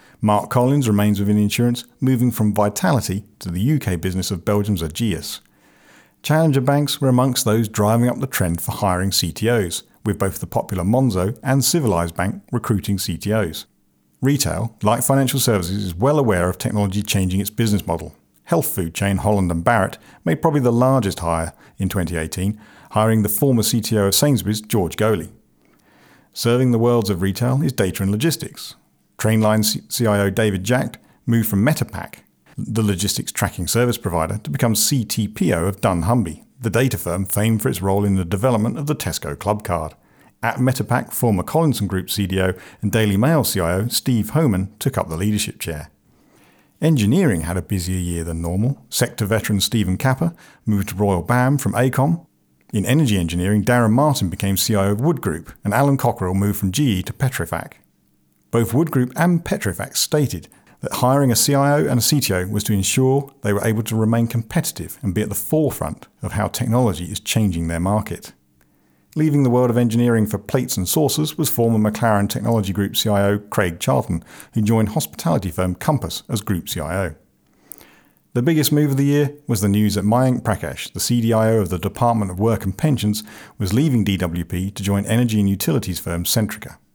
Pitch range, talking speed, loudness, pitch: 95-125 Hz, 175 wpm, -19 LUFS, 110 Hz